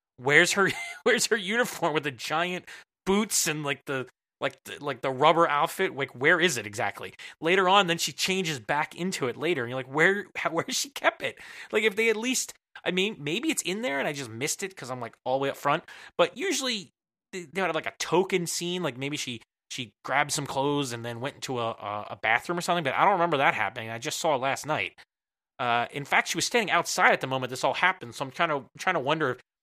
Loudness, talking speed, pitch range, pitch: -27 LUFS, 250 wpm, 130-185 Hz, 155 Hz